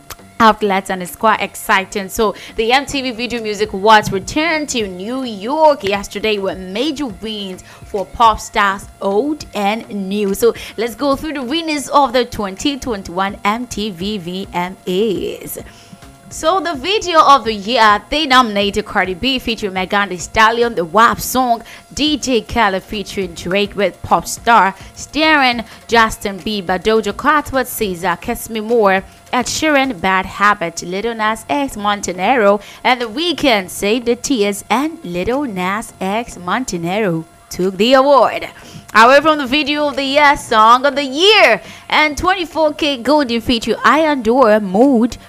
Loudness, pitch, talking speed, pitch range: -15 LUFS, 225 Hz, 145 wpm, 200-275 Hz